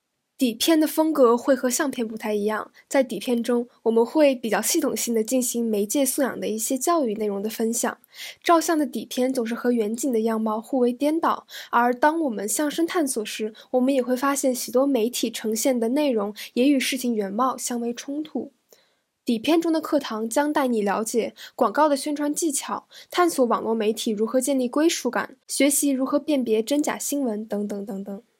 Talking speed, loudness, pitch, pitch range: 290 characters per minute, -23 LUFS, 255 Hz, 225-290 Hz